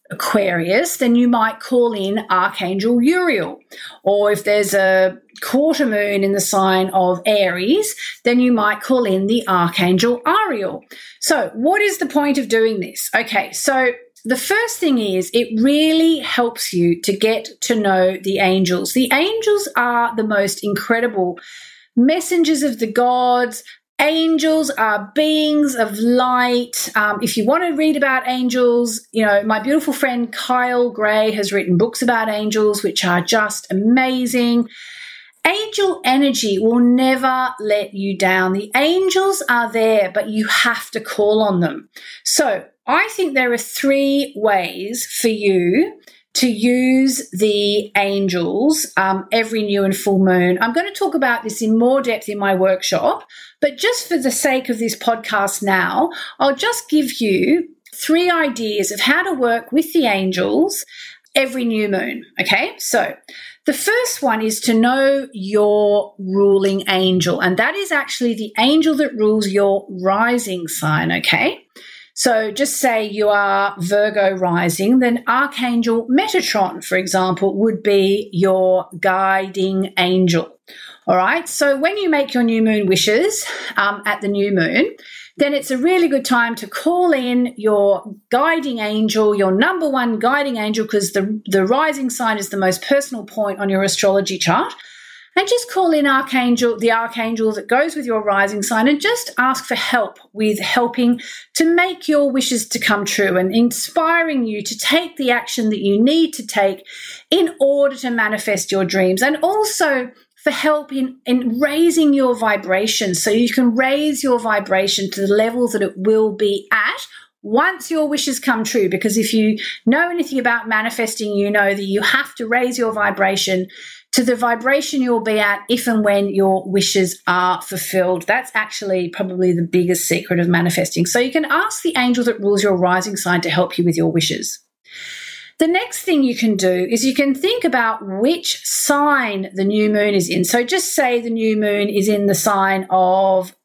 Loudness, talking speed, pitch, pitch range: -17 LUFS, 170 wpm, 230 Hz, 200-275 Hz